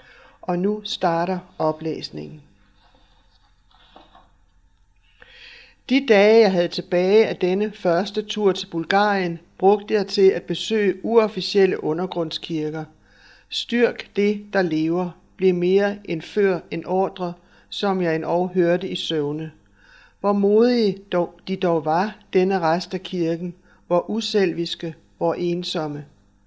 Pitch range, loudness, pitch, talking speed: 160-200 Hz, -21 LUFS, 180 Hz, 120 wpm